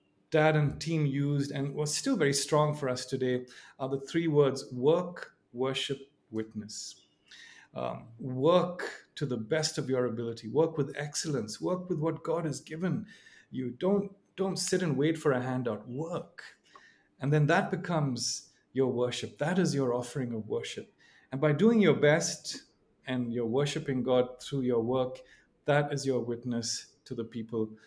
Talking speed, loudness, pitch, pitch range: 165 wpm, -31 LUFS, 140 Hz, 125-160 Hz